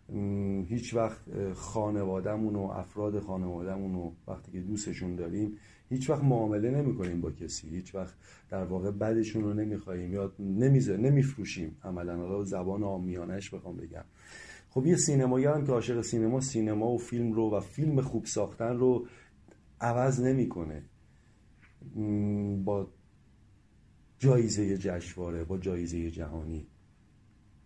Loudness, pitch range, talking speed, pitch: -31 LUFS, 95-115 Hz, 130 wpm, 100 Hz